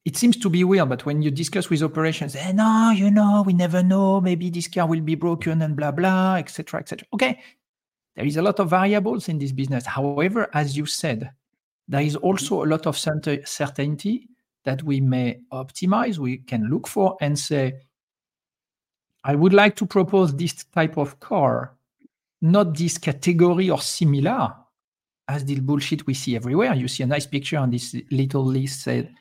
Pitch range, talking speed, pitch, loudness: 140-185 Hz, 190 wpm, 155 Hz, -22 LUFS